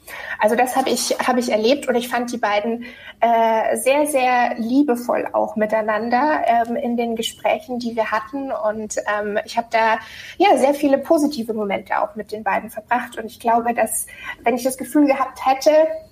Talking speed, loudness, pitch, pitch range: 185 wpm, -19 LUFS, 240 Hz, 220-275 Hz